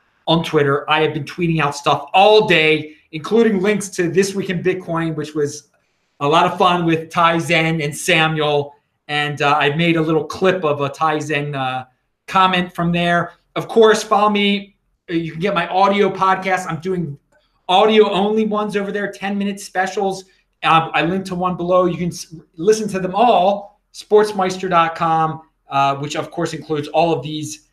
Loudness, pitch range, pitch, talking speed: -17 LUFS, 155-190 Hz, 170 Hz, 185 wpm